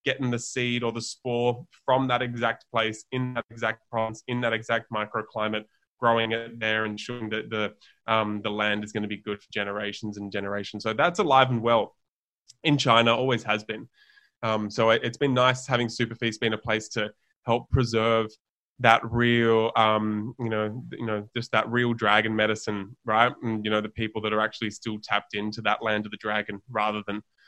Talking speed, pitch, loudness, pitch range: 200 wpm, 110 Hz, -26 LUFS, 105-120 Hz